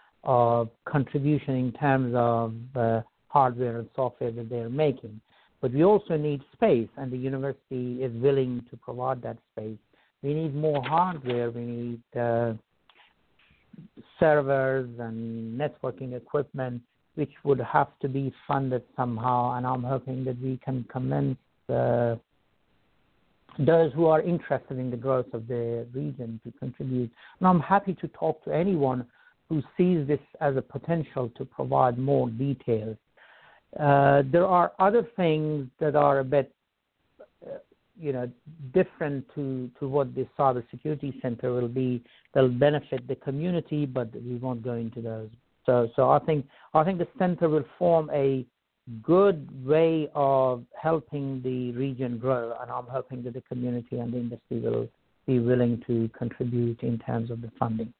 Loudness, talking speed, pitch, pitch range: -27 LUFS, 155 wpm, 130 Hz, 120-145 Hz